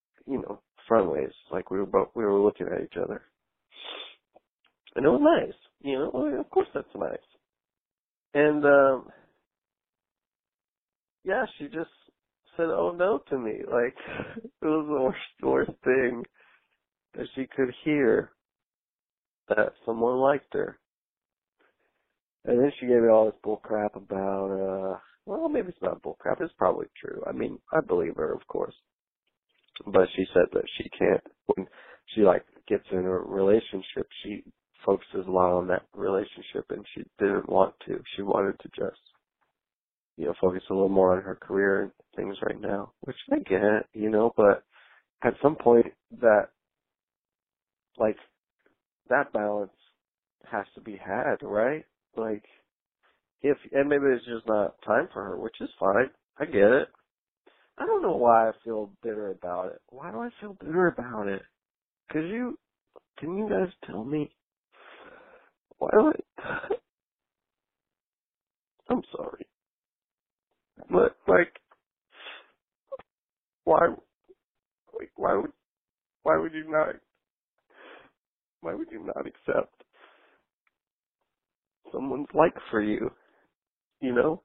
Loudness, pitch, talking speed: -27 LUFS, 140 Hz, 145 wpm